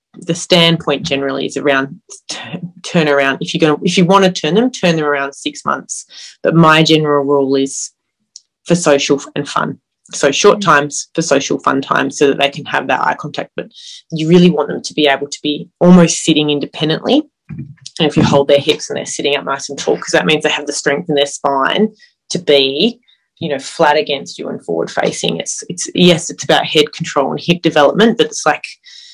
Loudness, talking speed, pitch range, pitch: -13 LUFS, 215 wpm, 140-170 Hz, 150 Hz